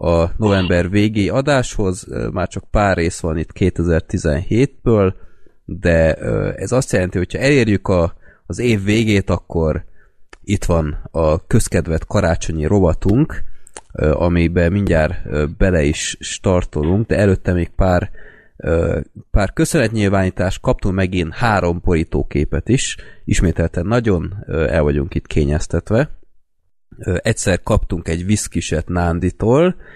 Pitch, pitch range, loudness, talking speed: 90 Hz, 85-105 Hz, -17 LUFS, 110 wpm